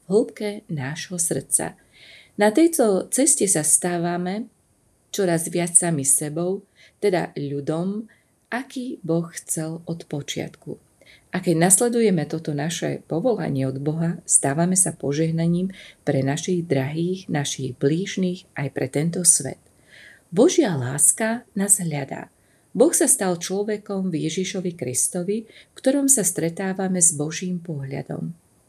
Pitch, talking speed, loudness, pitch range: 175 Hz, 120 wpm, -21 LUFS, 150-195 Hz